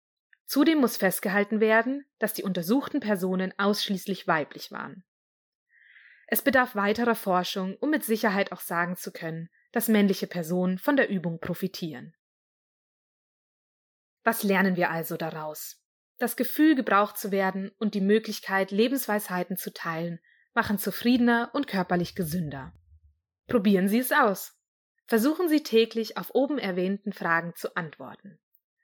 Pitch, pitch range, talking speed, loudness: 200 Hz, 180-230 Hz, 130 wpm, -26 LUFS